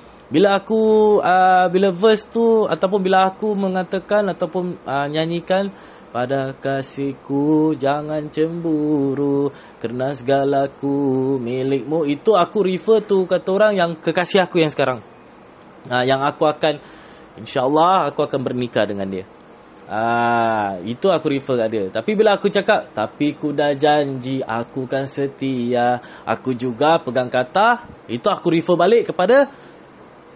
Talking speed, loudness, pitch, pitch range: 135 wpm, -19 LUFS, 150 Hz, 130-185 Hz